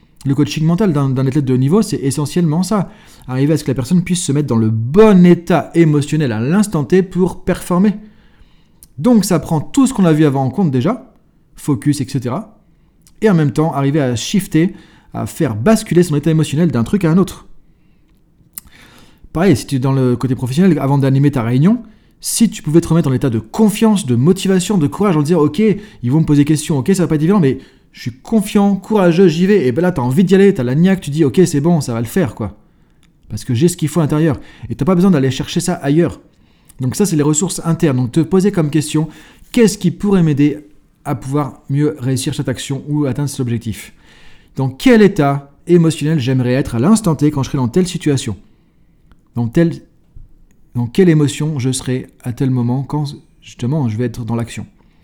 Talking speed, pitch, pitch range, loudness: 225 wpm, 155 Hz, 135-180 Hz, -14 LUFS